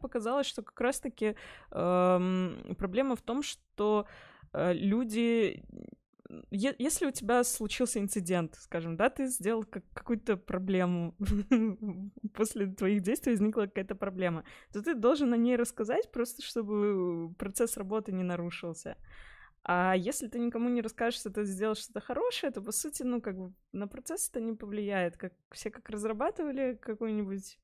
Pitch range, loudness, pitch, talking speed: 195-245 Hz, -32 LUFS, 215 Hz, 150 wpm